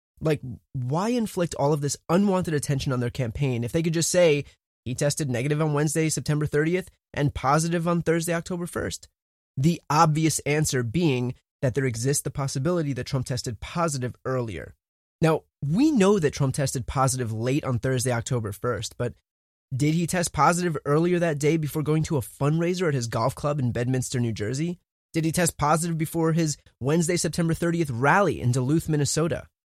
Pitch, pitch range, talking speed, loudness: 145 Hz, 130-165 Hz, 180 wpm, -25 LUFS